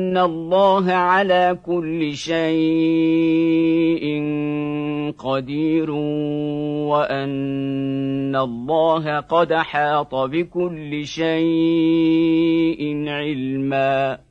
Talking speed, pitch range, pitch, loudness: 55 wpm, 145-165 Hz, 155 Hz, -20 LUFS